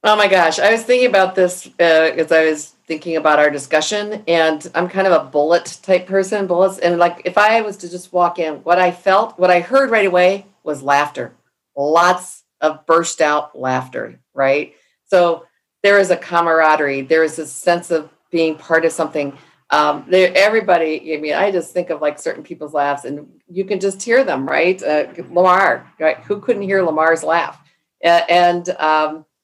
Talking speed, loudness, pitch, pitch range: 190 wpm, -16 LUFS, 170 Hz, 155-185 Hz